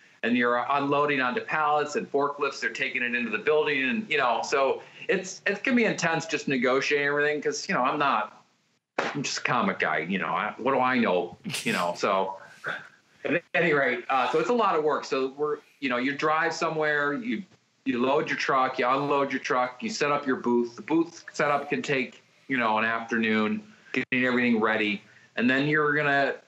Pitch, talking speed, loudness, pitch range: 145 Hz, 210 wpm, -26 LUFS, 125-155 Hz